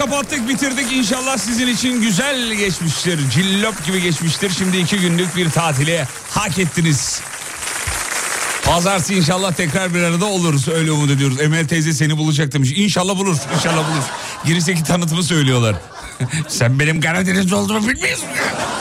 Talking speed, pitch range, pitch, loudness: 135 wpm, 155-200 Hz, 175 Hz, -17 LUFS